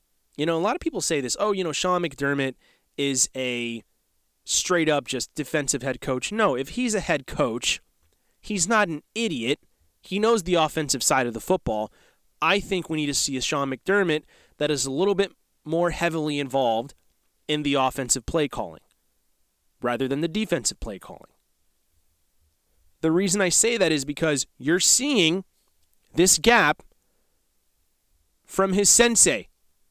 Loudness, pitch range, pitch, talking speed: -23 LUFS, 110-185 Hz, 145 Hz, 165 wpm